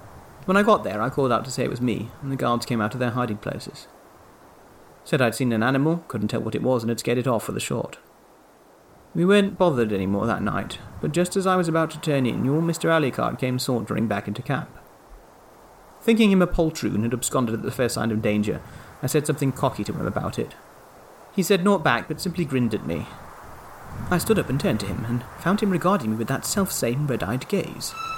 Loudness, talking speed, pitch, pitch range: -24 LUFS, 230 wpm, 130 Hz, 115-170 Hz